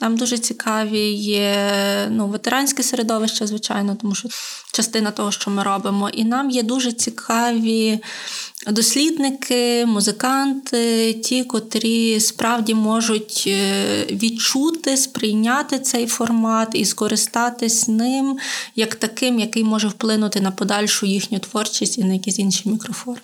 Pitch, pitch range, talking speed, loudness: 225 Hz, 210-240 Hz, 120 wpm, -19 LUFS